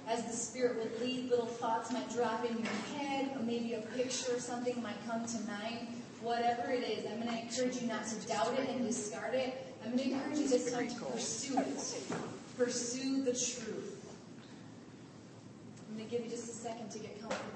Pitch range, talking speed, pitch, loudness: 230-250 Hz, 210 wpm, 235 Hz, -37 LUFS